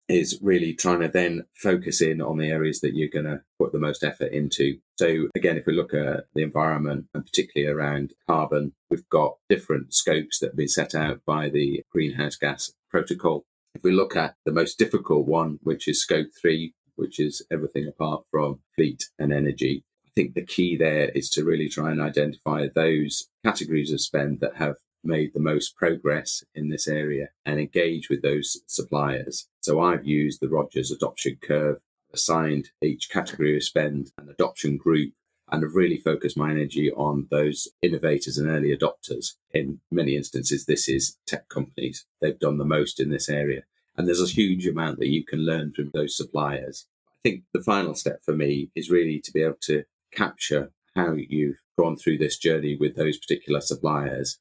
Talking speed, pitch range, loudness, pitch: 190 wpm, 70-80 Hz, -25 LUFS, 75 Hz